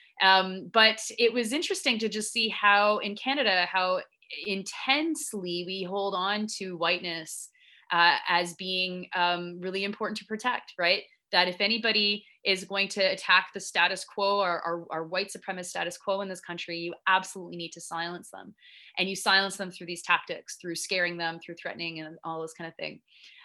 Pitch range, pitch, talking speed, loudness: 175-210 Hz, 190 Hz, 180 wpm, -27 LUFS